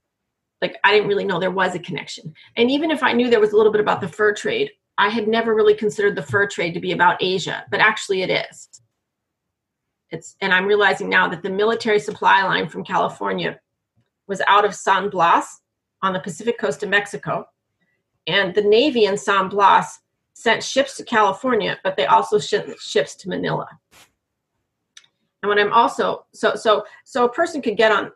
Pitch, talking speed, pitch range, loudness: 205 Hz, 195 wpm, 195-235 Hz, -19 LUFS